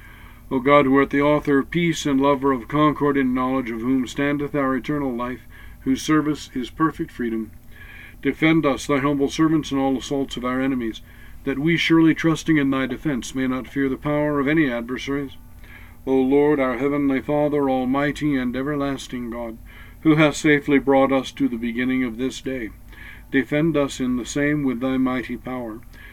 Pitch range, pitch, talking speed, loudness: 125-145 Hz, 135 Hz, 185 wpm, -21 LUFS